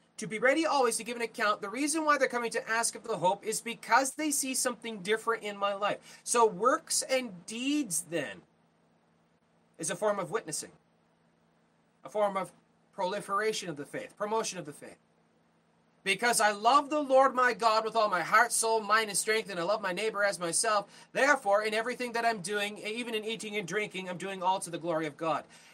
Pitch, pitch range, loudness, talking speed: 215 Hz, 185-235 Hz, -30 LUFS, 205 wpm